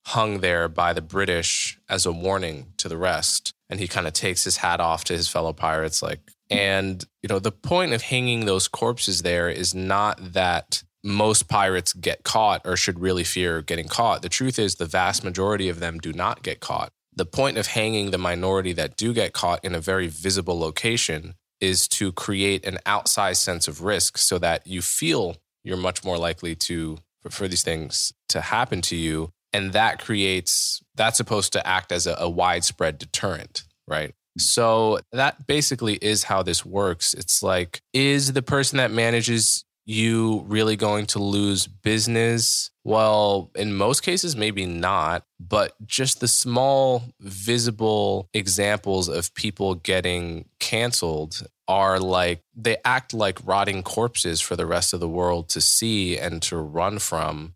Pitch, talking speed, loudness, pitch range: 95 Hz, 175 wpm, -22 LUFS, 90-110 Hz